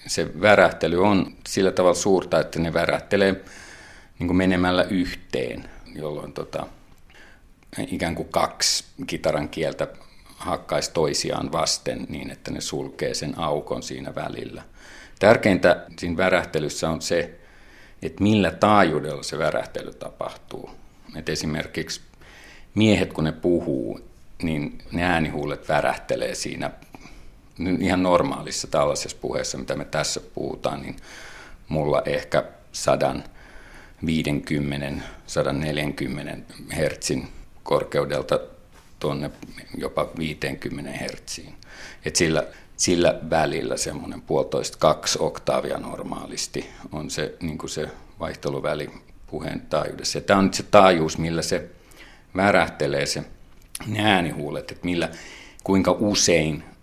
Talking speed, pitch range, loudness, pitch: 105 wpm, 80-95 Hz, -24 LUFS, 90 Hz